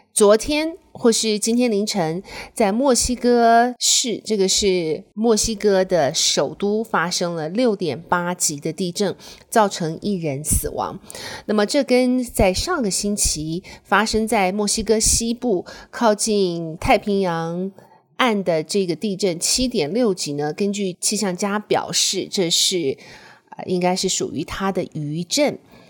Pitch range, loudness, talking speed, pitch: 180-230 Hz, -19 LUFS, 210 characters per minute, 205 Hz